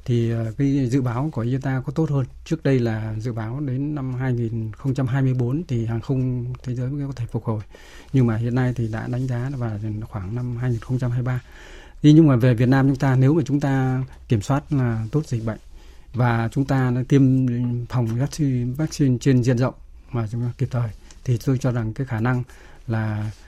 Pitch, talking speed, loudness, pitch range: 125 Hz, 205 wpm, -22 LUFS, 115-135 Hz